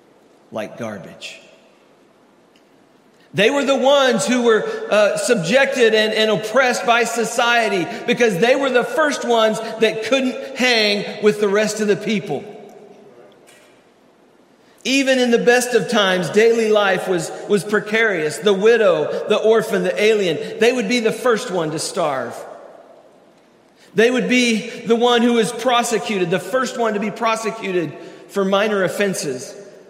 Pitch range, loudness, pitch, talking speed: 205-240 Hz, -17 LUFS, 220 Hz, 145 wpm